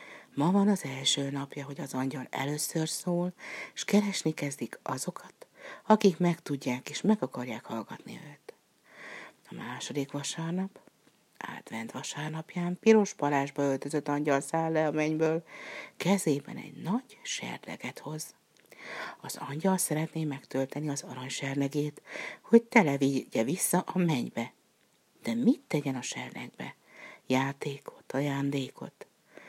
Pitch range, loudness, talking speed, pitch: 140-175 Hz, -31 LUFS, 120 wpm, 150 Hz